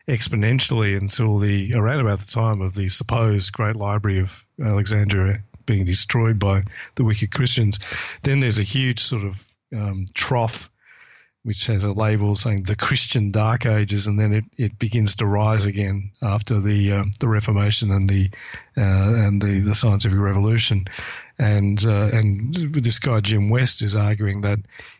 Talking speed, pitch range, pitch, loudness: 165 wpm, 100-115 Hz, 105 Hz, -20 LUFS